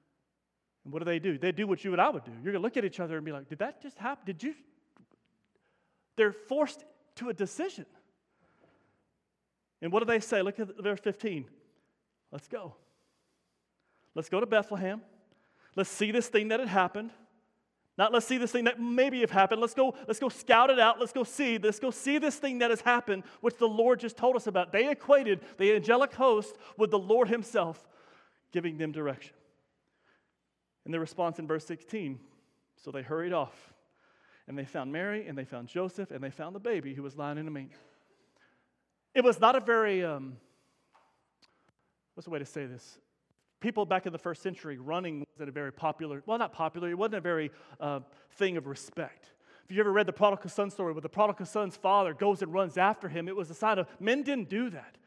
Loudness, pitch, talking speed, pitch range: -30 LUFS, 200 Hz, 210 wpm, 165-230 Hz